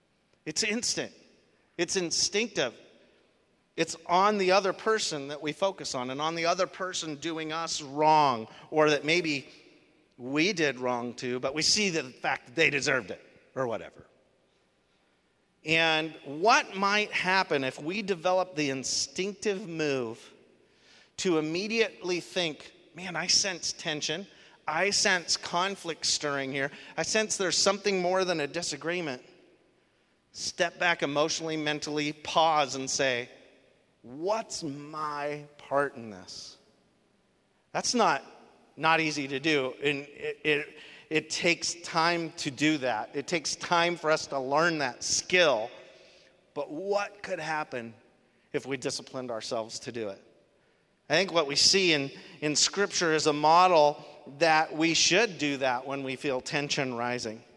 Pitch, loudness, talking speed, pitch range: 155 Hz, -28 LUFS, 145 wpm, 140-175 Hz